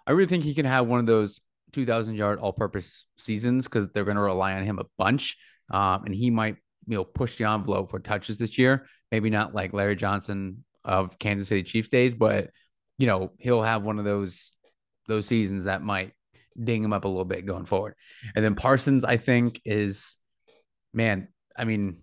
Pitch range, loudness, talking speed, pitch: 100-120 Hz, -26 LUFS, 205 wpm, 110 Hz